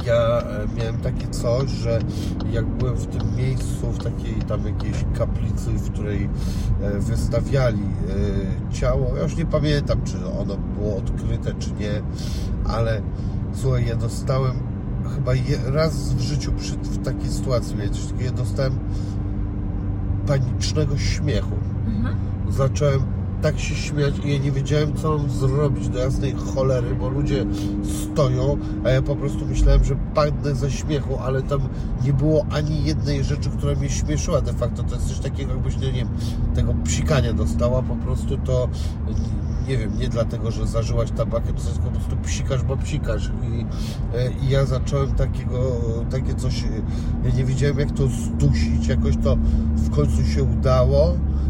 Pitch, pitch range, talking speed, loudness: 110 Hz, 100-130 Hz, 150 wpm, -23 LUFS